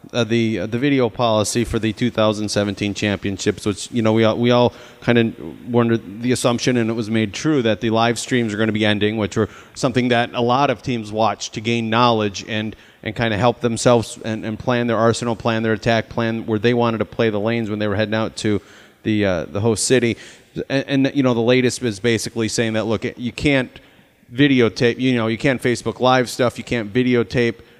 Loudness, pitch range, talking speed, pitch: -19 LUFS, 110-120 Hz, 230 wpm, 115 Hz